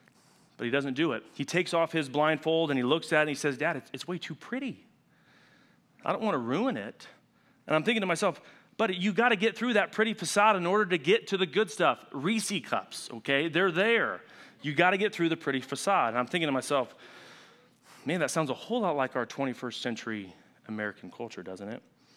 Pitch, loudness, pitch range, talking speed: 165 Hz, -29 LUFS, 140-200 Hz, 225 wpm